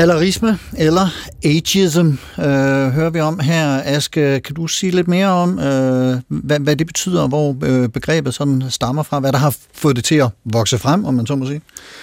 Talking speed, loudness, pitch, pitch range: 195 wpm, -16 LUFS, 145 Hz, 135-165 Hz